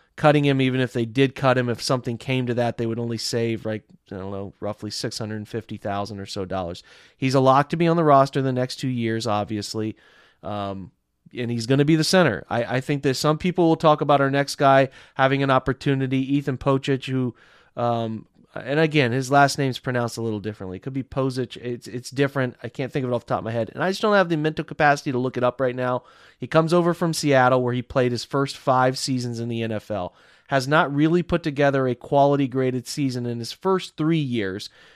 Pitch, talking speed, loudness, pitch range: 130 Hz, 235 wpm, -22 LUFS, 115-140 Hz